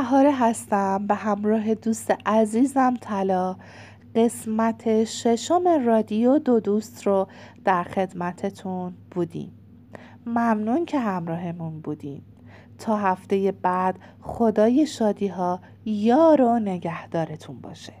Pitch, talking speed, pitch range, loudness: 210 Hz, 100 wpm, 185-230 Hz, -23 LUFS